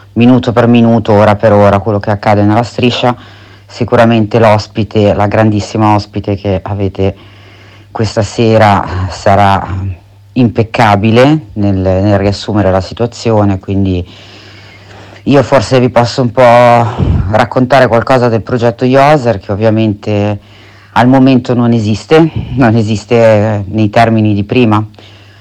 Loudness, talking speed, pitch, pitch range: -9 LUFS, 120 wpm, 105 Hz, 100-120 Hz